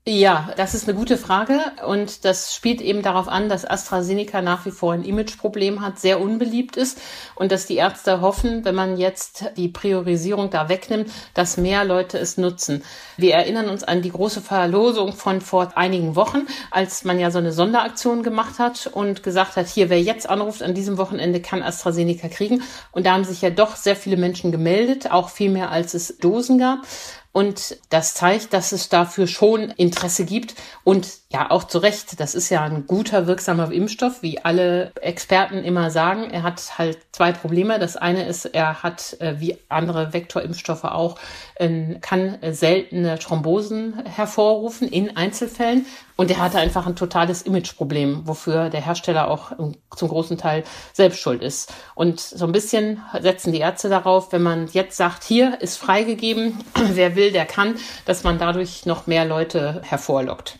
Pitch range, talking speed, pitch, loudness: 175-205 Hz, 175 wpm, 185 Hz, -20 LUFS